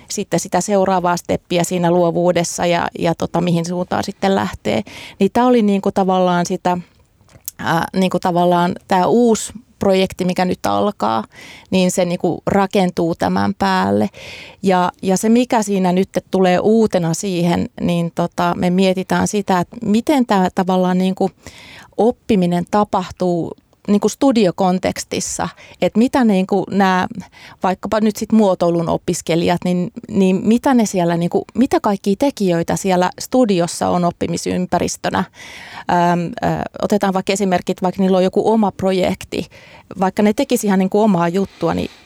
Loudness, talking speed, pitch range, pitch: -17 LUFS, 140 wpm, 175-200 Hz, 185 Hz